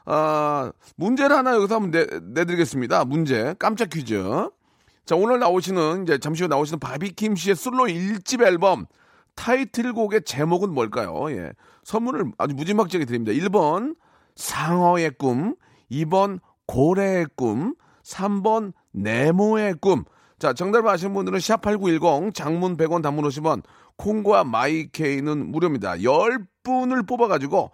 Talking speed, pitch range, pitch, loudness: 280 characters per minute, 155-215 Hz, 180 Hz, -22 LUFS